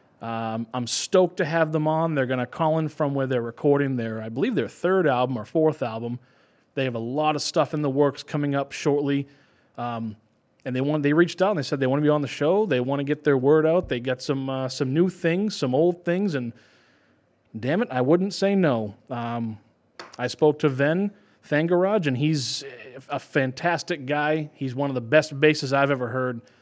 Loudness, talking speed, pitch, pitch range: -24 LUFS, 220 wpm, 140 Hz, 125-155 Hz